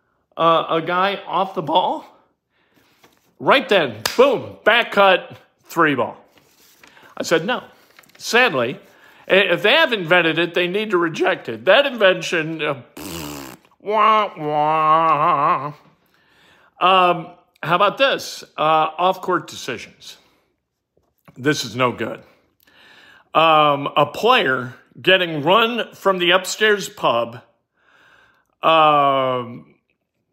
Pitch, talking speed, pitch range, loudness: 170 Hz, 105 wpm, 150-190 Hz, -17 LUFS